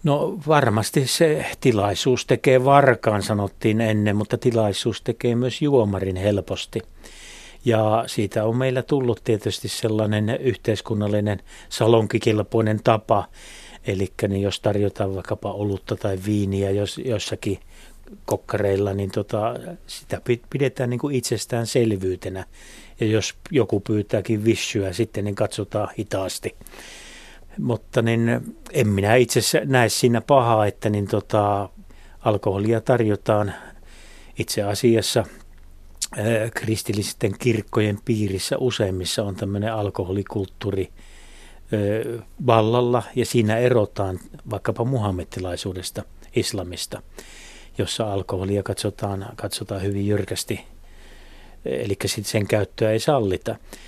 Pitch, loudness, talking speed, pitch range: 105 Hz, -22 LUFS, 100 wpm, 100-115 Hz